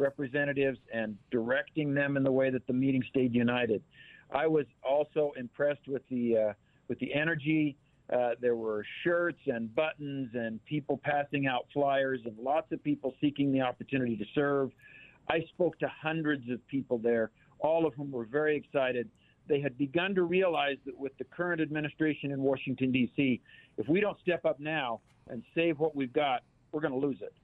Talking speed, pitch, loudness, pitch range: 185 wpm, 140 Hz, -32 LUFS, 125-150 Hz